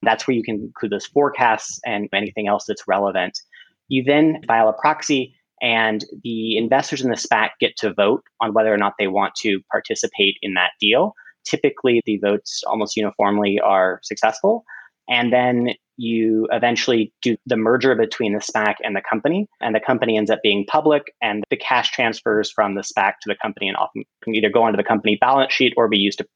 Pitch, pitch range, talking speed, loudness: 115 Hz, 105-130 Hz, 200 wpm, -19 LUFS